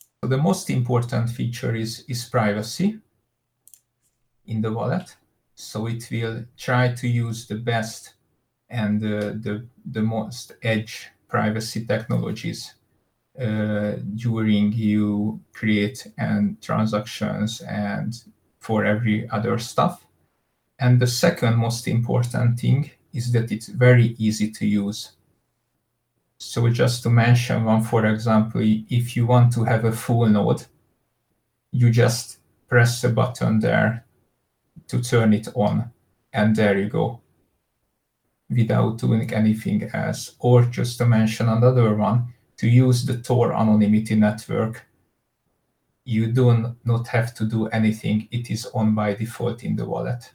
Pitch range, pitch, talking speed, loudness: 110-120 Hz, 115 Hz, 130 wpm, -22 LUFS